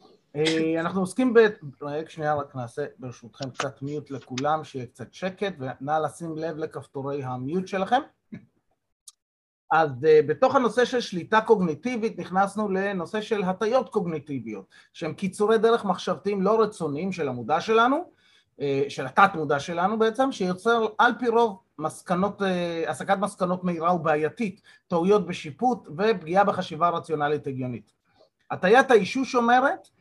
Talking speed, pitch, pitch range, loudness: 125 wpm, 175 Hz, 150-215 Hz, -25 LUFS